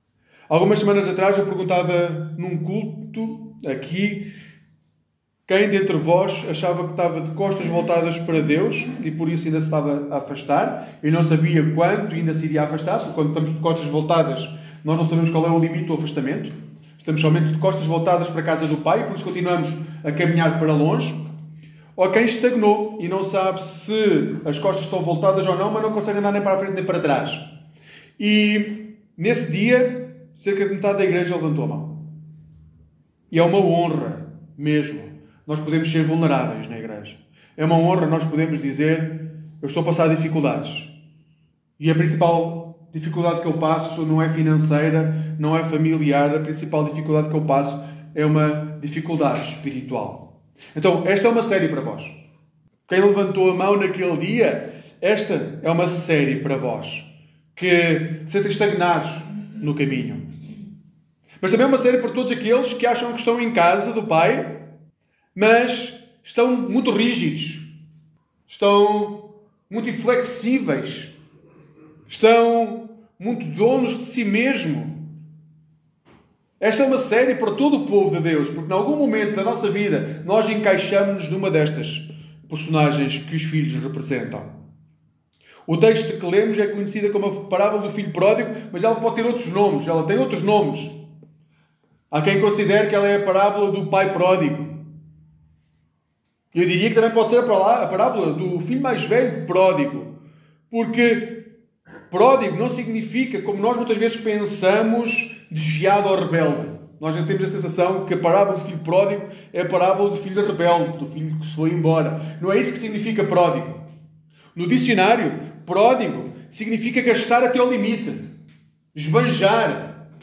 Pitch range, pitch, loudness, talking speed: 155-205 Hz, 170 Hz, -20 LUFS, 160 wpm